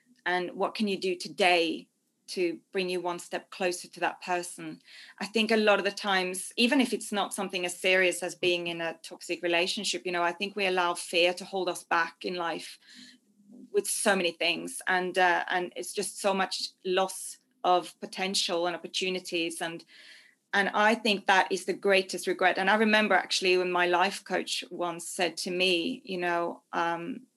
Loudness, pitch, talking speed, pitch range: -28 LUFS, 185 Hz, 195 wpm, 175-205 Hz